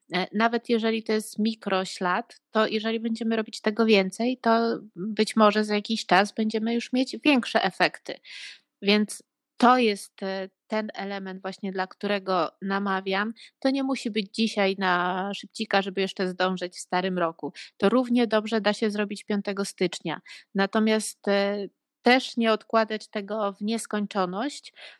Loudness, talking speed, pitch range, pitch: -26 LUFS, 140 wpm, 195-225 Hz, 210 Hz